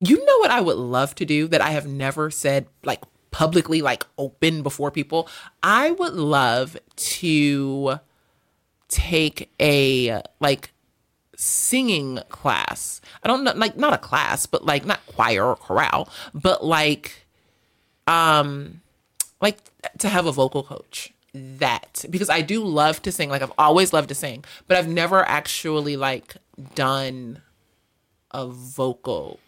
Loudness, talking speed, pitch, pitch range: -21 LUFS, 145 wpm, 150 Hz, 135-180 Hz